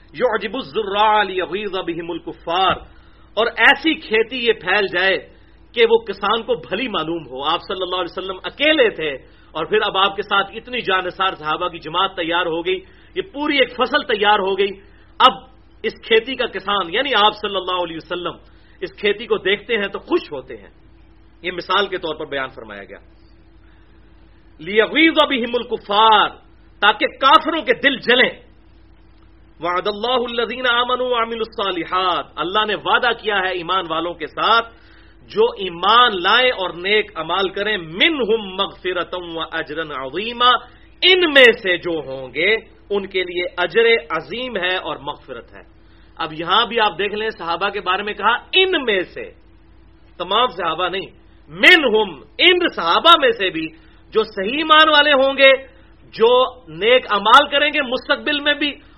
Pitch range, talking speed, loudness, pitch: 175-260 Hz, 165 wpm, -17 LUFS, 205 Hz